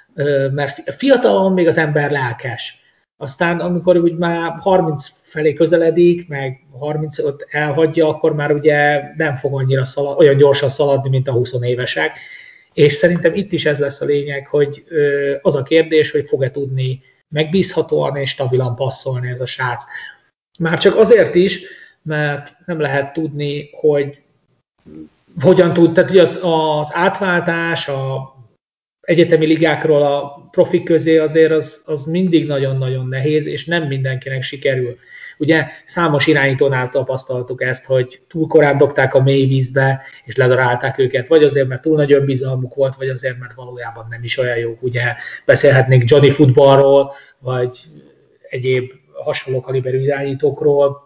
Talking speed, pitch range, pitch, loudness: 145 wpm, 130-160 Hz, 145 Hz, -15 LUFS